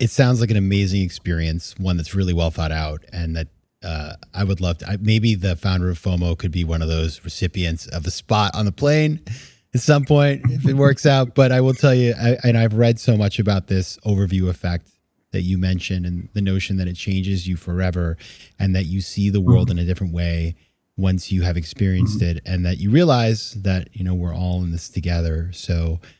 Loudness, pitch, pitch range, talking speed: -20 LUFS, 95 Hz, 85-110 Hz, 225 wpm